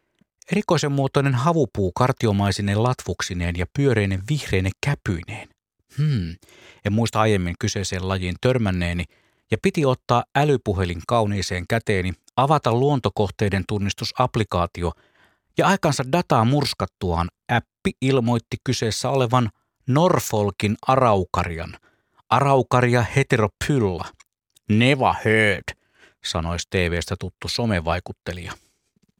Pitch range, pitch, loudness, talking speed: 95-130 Hz, 110 Hz, -22 LUFS, 90 wpm